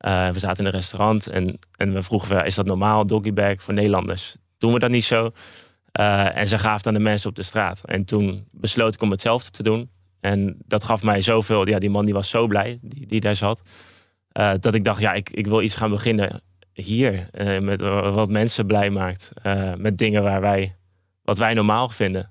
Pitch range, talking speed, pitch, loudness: 95-110 Hz, 225 wpm, 105 Hz, -21 LUFS